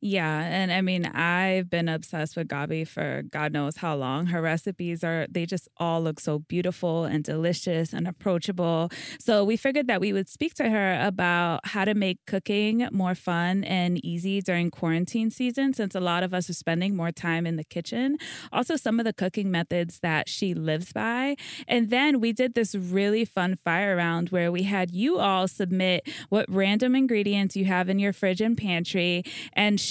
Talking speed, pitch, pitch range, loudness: 195 wpm, 185 Hz, 170-205 Hz, -26 LUFS